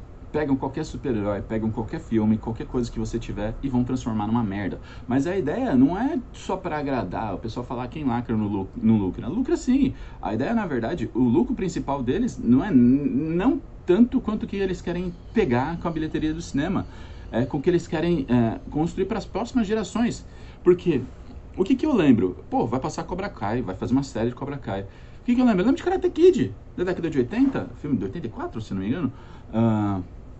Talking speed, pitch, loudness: 215 wpm, 140 Hz, -24 LUFS